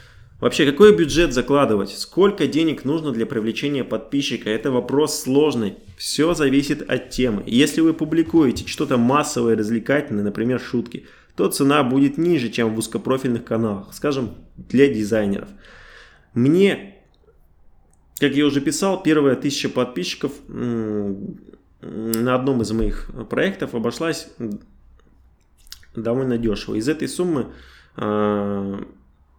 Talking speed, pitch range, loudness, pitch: 110 wpm, 105-145 Hz, -20 LUFS, 120 Hz